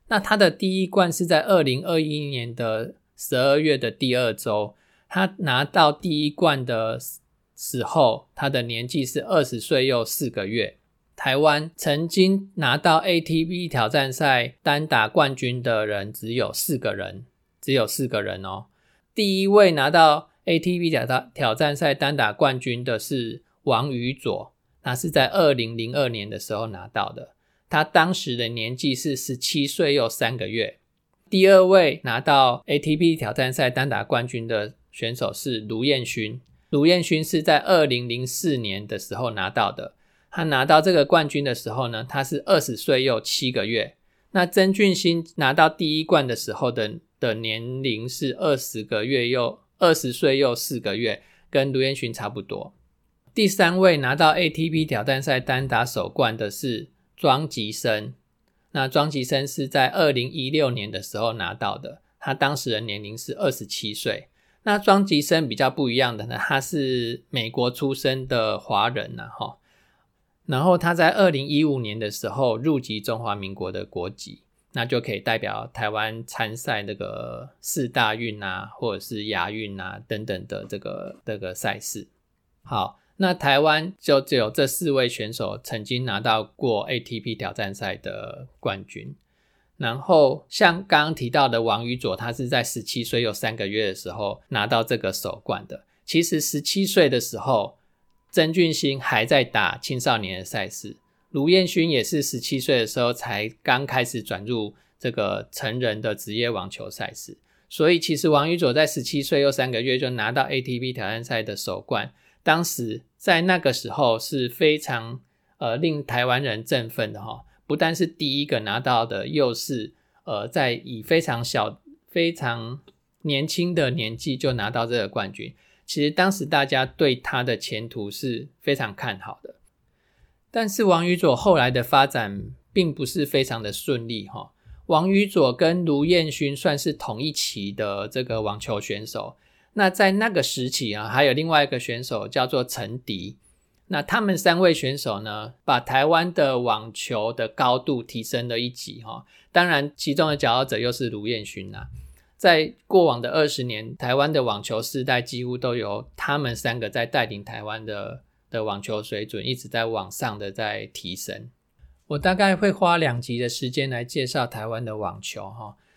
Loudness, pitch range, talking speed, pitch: -23 LUFS, 115-155 Hz, 250 characters per minute, 130 Hz